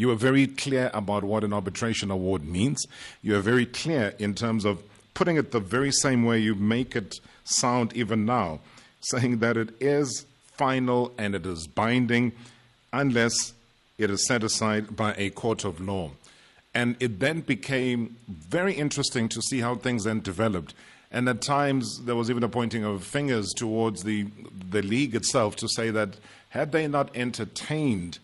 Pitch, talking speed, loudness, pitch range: 115 Hz, 175 wpm, -26 LUFS, 105-125 Hz